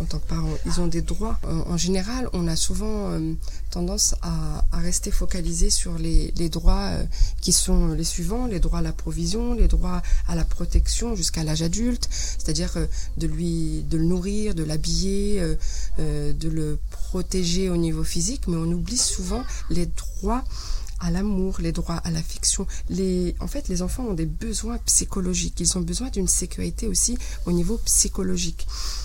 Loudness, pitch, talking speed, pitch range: -25 LUFS, 175 Hz, 185 wpm, 165-195 Hz